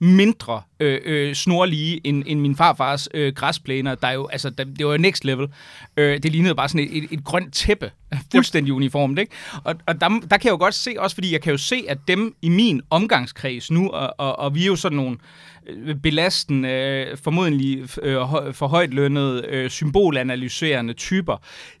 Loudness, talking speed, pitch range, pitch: -20 LUFS, 195 wpm, 135-175 Hz, 145 Hz